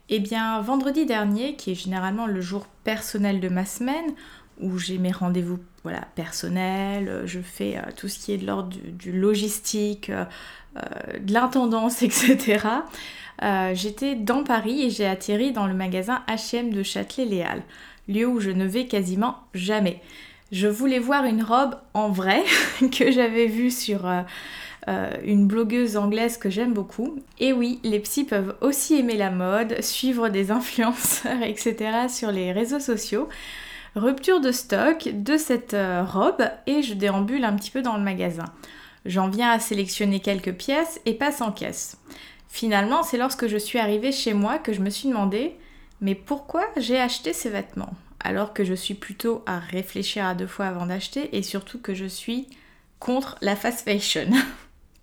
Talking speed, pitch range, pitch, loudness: 170 wpm, 195-250 Hz, 220 Hz, -24 LUFS